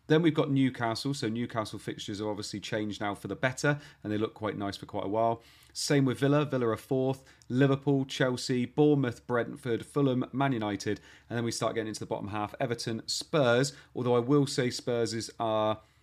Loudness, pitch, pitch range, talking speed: -30 LUFS, 120 Hz, 110-135 Hz, 200 wpm